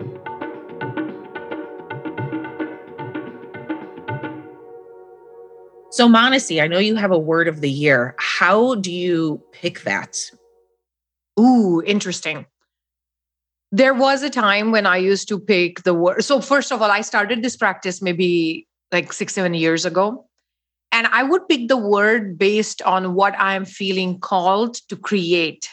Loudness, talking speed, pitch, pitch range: -18 LUFS, 135 wpm, 185 Hz, 160-215 Hz